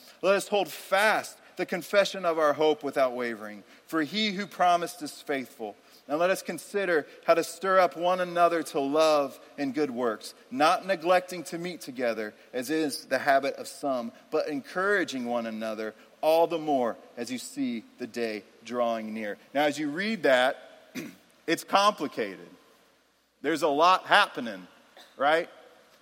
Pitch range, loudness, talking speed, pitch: 135-185 Hz, -27 LUFS, 160 wpm, 165 Hz